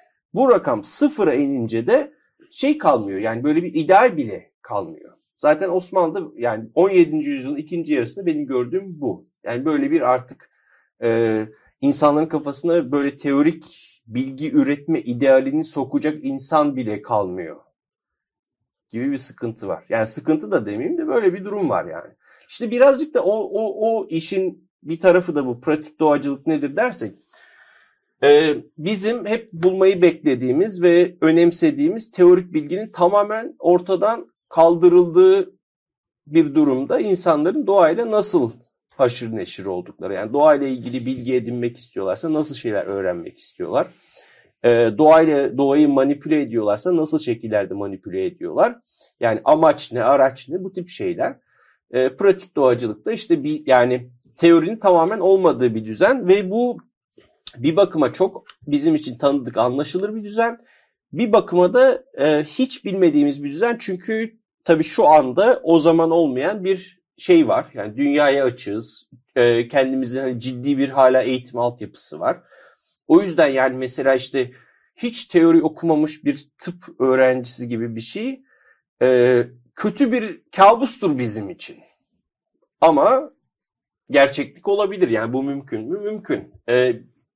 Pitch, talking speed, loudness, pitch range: 160 Hz, 135 wpm, -19 LUFS, 130-215 Hz